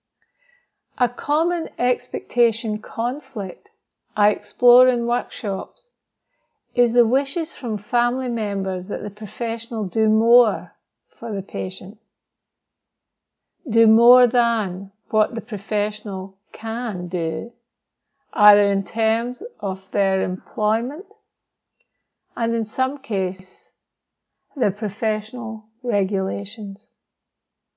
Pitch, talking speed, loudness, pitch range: 225 Hz, 95 wpm, -21 LUFS, 200-245 Hz